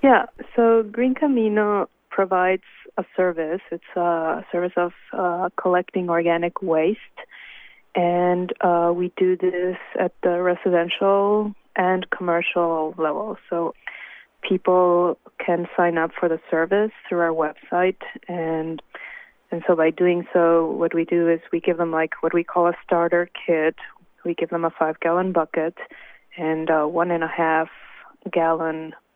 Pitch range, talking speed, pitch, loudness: 165-185 Hz, 140 wpm, 175 Hz, -22 LUFS